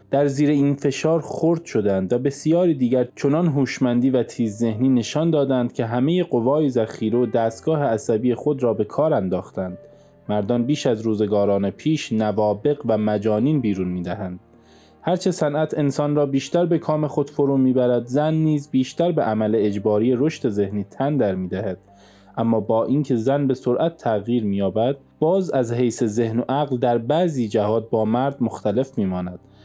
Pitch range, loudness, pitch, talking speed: 110-145 Hz, -21 LUFS, 125 Hz, 165 wpm